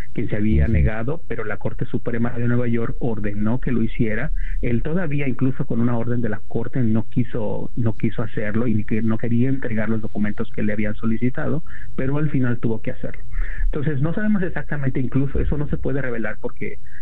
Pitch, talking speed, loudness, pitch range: 120 Hz, 195 wpm, -24 LUFS, 110-135 Hz